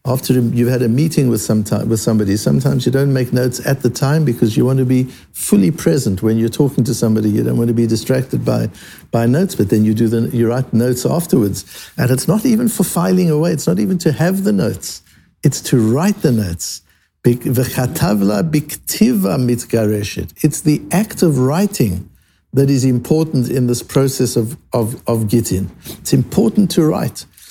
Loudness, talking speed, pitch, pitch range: -15 LUFS, 180 wpm, 125 Hz, 115-155 Hz